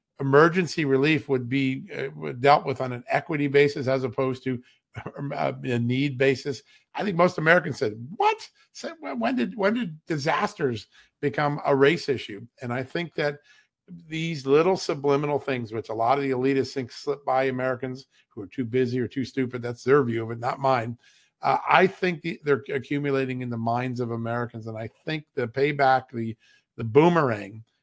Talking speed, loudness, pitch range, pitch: 175 wpm, -25 LUFS, 125-150 Hz, 135 Hz